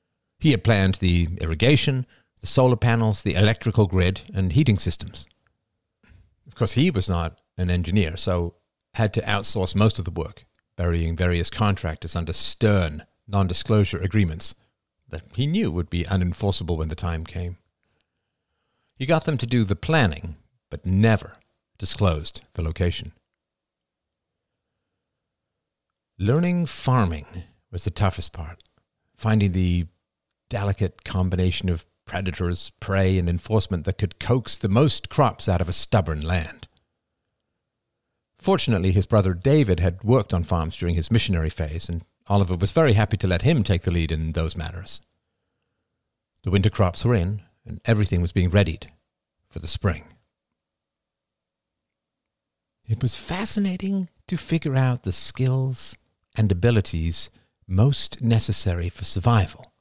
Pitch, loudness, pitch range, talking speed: 100 Hz, -23 LUFS, 90-115 Hz, 135 wpm